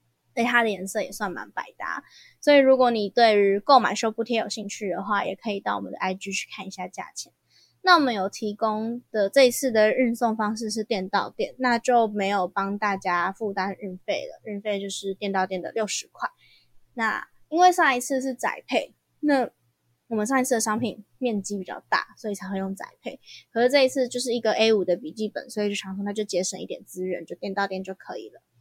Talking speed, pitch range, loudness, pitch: 315 characters per minute, 195-240 Hz, -24 LUFS, 210 Hz